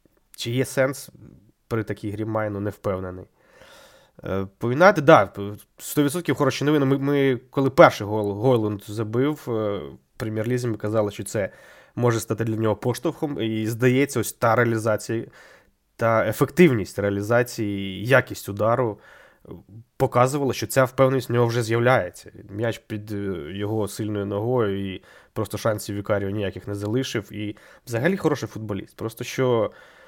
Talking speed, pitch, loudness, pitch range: 135 wpm, 115 Hz, -23 LUFS, 105-130 Hz